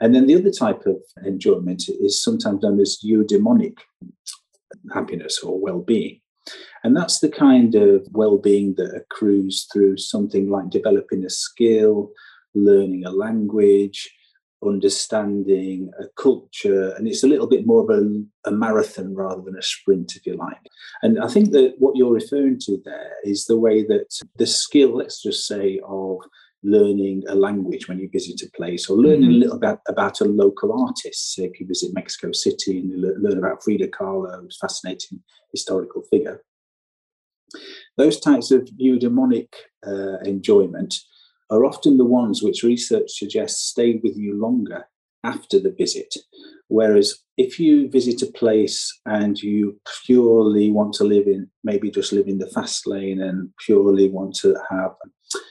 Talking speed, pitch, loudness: 160 wpm, 110 Hz, -19 LUFS